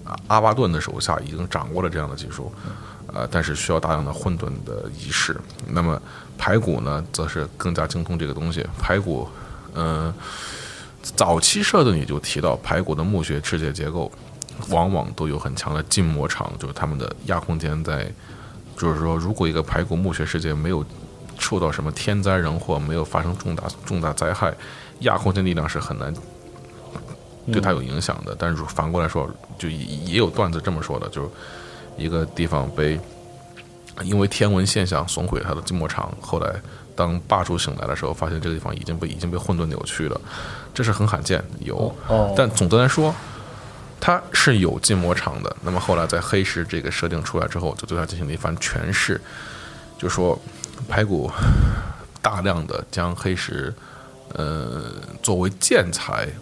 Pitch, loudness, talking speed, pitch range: 85 Hz, -23 LUFS, 265 characters per minute, 80-100 Hz